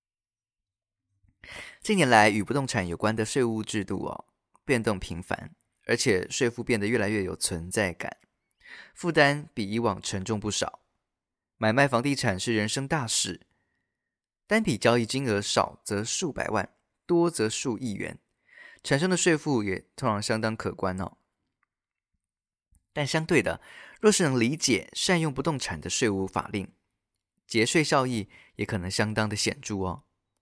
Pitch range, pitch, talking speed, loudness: 95-130 Hz, 110 Hz, 220 characters per minute, -27 LUFS